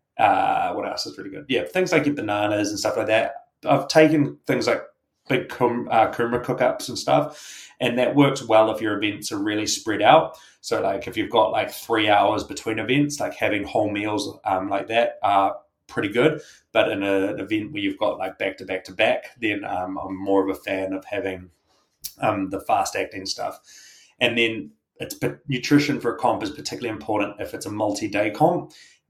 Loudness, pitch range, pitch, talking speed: -23 LUFS, 95-145 Hz, 110 Hz, 210 wpm